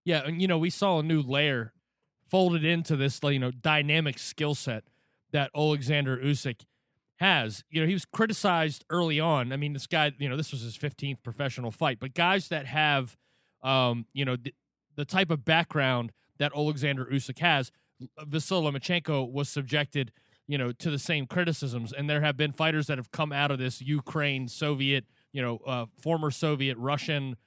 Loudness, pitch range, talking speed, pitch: -28 LUFS, 130-155 Hz, 185 wpm, 145 Hz